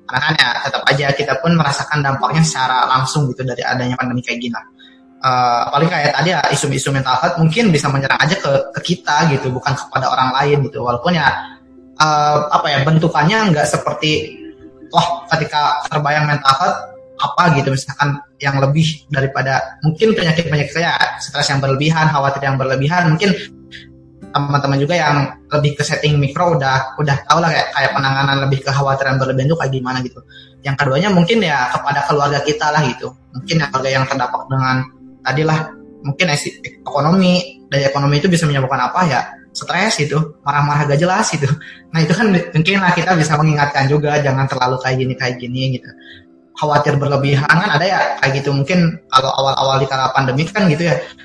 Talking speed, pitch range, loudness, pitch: 185 wpm, 135-160 Hz, -15 LUFS, 145 Hz